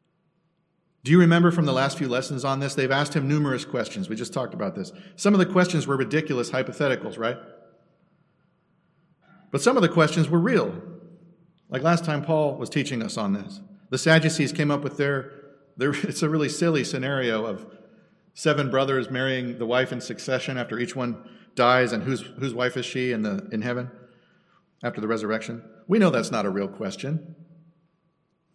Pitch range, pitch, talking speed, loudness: 130-170 Hz, 150 Hz, 185 wpm, -24 LUFS